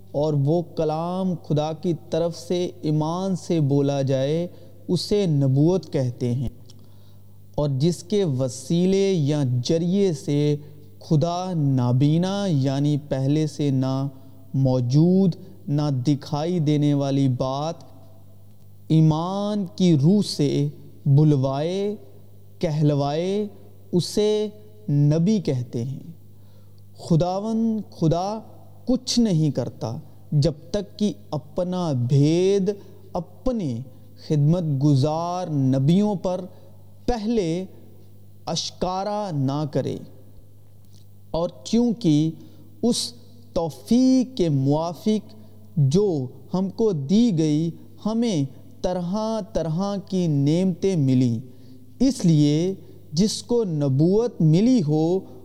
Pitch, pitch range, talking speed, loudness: 155 Hz, 130-185 Hz, 95 wpm, -23 LUFS